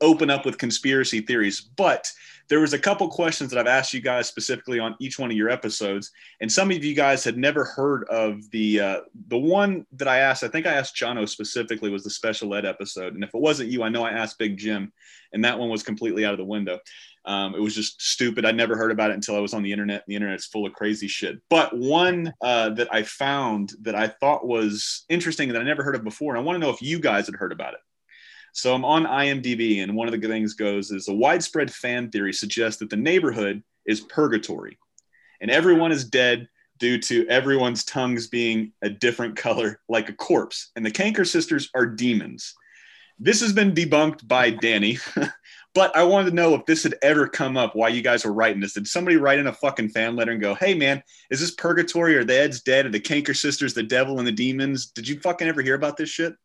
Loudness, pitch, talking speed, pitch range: -22 LUFS, 120 Hz, 240 wpm, 110-145 Hz